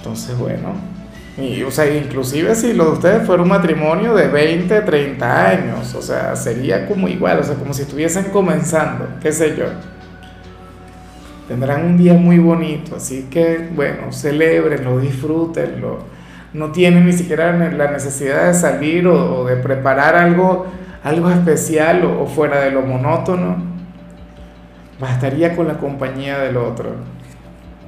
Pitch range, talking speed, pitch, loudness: 135-170 Hz, 145 wpm, 155 Hz, -15 LUFS